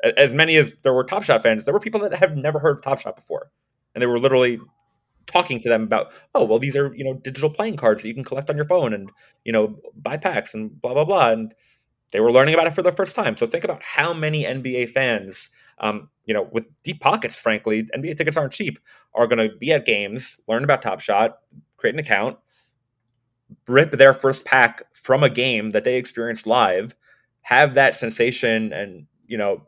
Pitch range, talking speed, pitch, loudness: 115-155 Hz, 220 wpm, 130 Hz, -20 LUFS